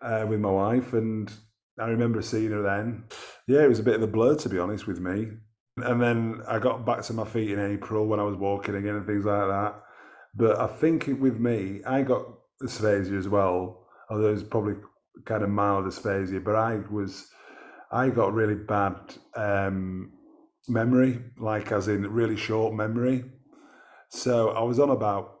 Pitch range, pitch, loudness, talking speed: 100-115 Hz, 110 Hz, -26 LUFS, 190 wpm